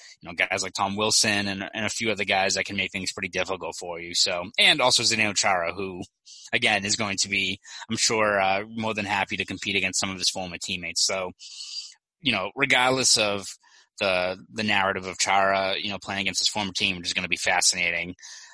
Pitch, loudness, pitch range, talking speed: 95 Hz, -23 LUFS, 95-105 Hz, 220 wpm